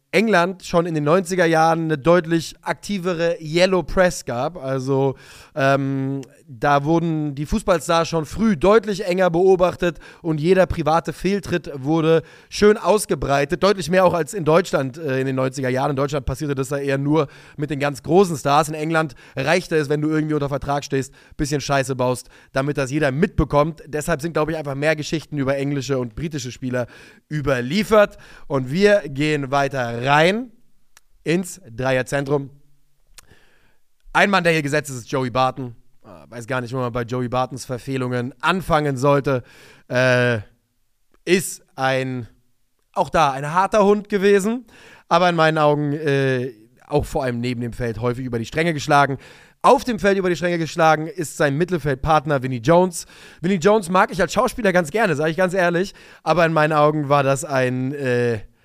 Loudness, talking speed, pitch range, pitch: -20 LUFS, 175 wpm, 135-175 Hz, 150 Hz